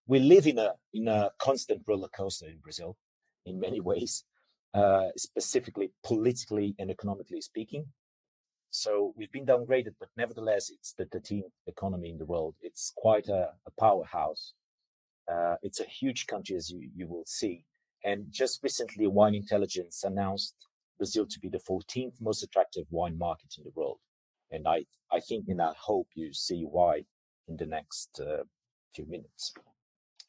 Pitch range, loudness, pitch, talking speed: 95-130 Hz, -31 LUFS, 105 Hz, 160 wpm